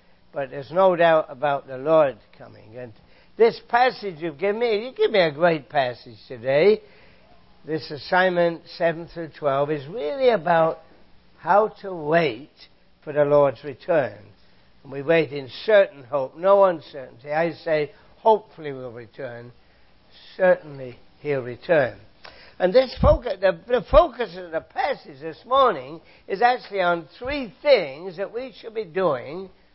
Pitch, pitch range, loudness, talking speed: 165 Hz, 145-200 Hz, -22 LUFS, 145 wpm